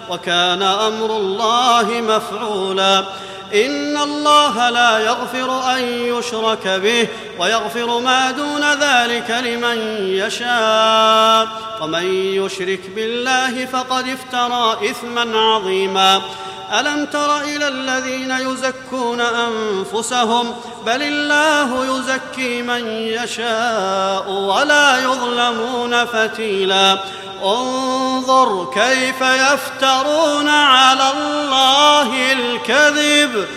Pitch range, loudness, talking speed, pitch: 220-260 Hz, -16 LUFS, 80 wpm, 240 Hz